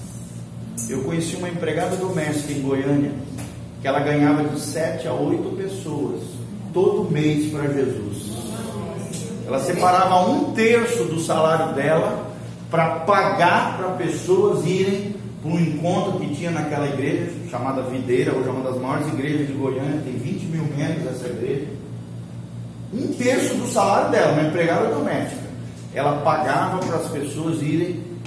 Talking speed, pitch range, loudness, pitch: 145 wpm, 130-170 Hz, -22 LUFS, 150 Hz